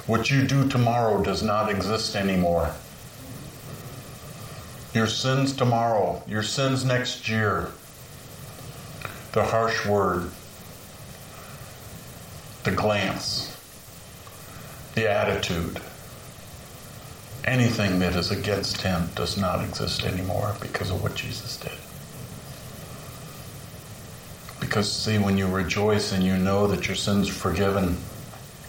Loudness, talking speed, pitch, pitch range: -25 LUFS, 100 wpm, 110 Hz, 100-125 Hz